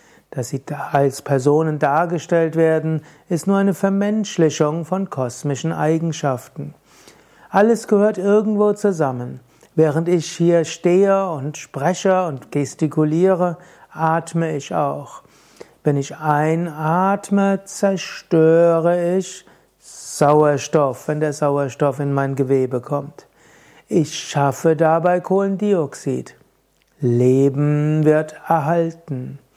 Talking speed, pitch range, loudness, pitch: 95 wpm, 145-180 Hz, -19 LUFS, 160 Hz